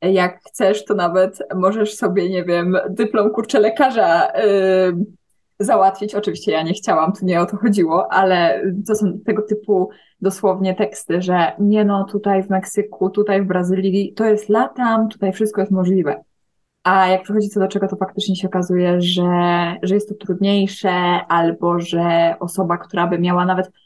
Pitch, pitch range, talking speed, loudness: 190 Hz, 180-205 Hz, 170 wpm, -17 LUFS